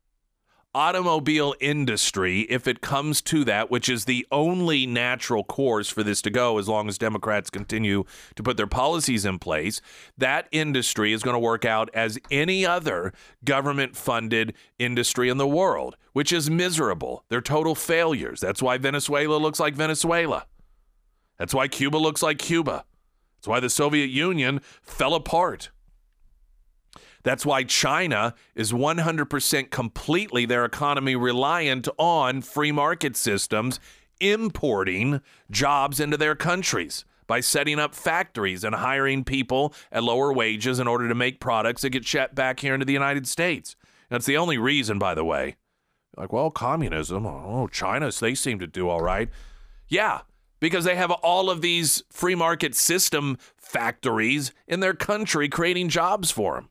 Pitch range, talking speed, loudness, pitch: 115-155 Hz, 155 wpm, -24 LUFS, 135 Hz